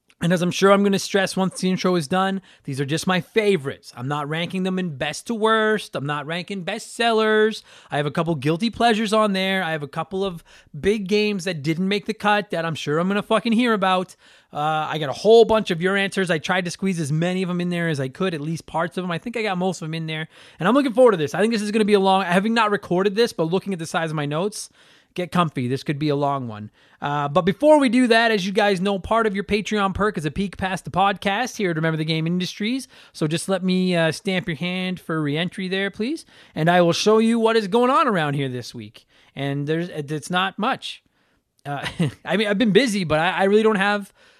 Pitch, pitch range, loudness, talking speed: 185 Hz, 160-210 Hz, -21 LUFS, 270 wpm